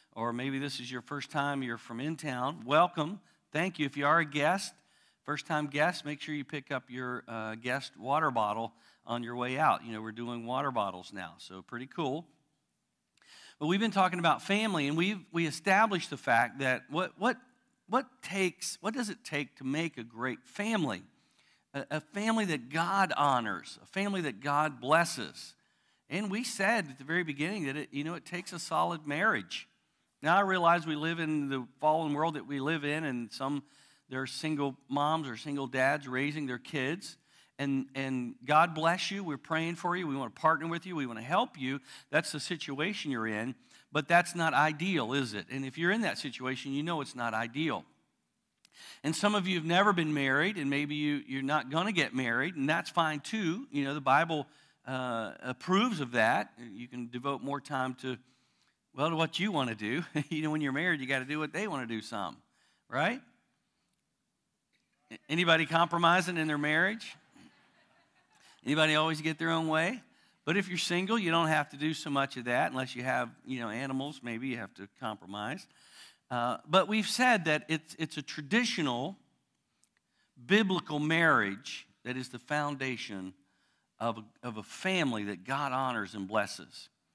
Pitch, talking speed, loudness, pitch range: 150 Hz, 195 wpm, -32 LUFS, 130-170 Hz